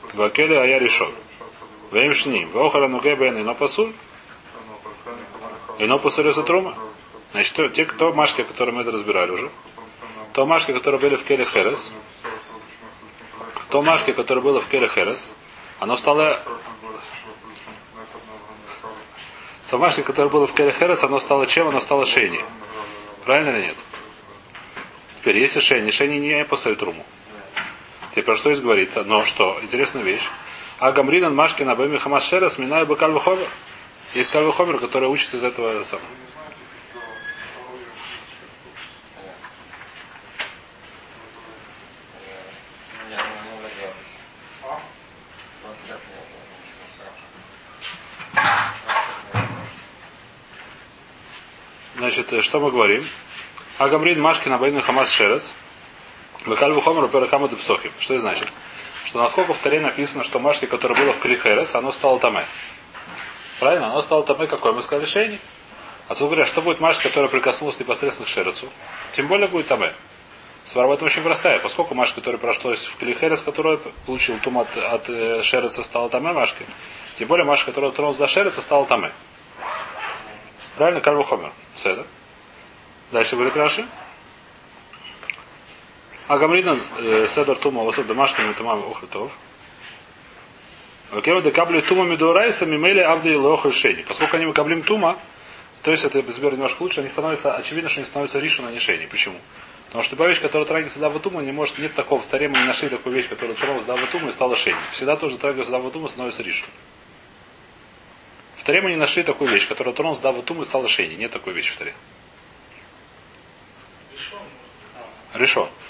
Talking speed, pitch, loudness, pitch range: 140 wpm, 145 Hz, -19 LUFS, 130-165 Hz